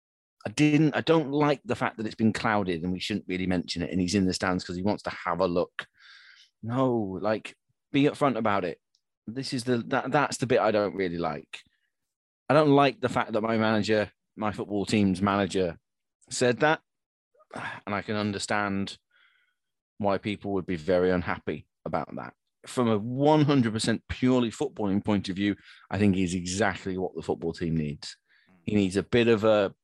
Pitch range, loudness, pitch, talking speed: 95-125 Hz, -27 LUFS, 105 Hz, 190 wpm